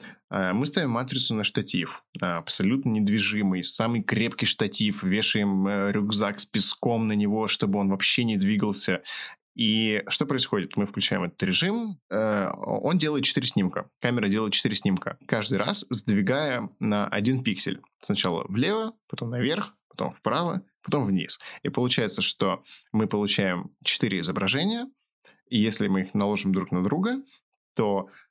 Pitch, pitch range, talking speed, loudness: 110 Hz, 105-145 Hz, 140 wpm, -26 LUFS